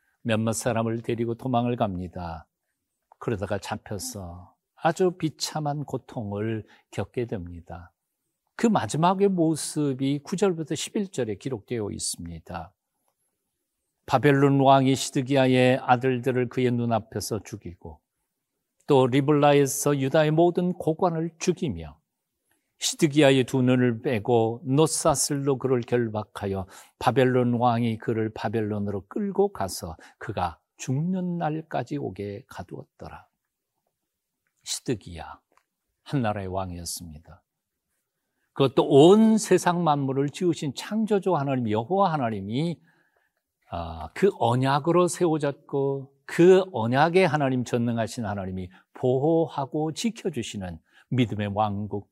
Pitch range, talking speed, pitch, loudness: 110-155 Hz, 255 characters per minute, 130 Hz, -25 LUFS